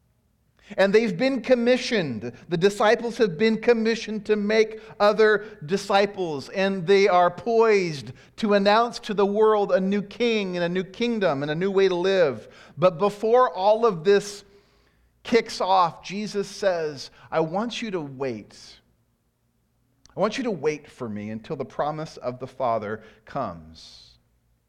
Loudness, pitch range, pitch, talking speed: -23 LUFS, 150-220 Hz, 195 Hz, 155 wpm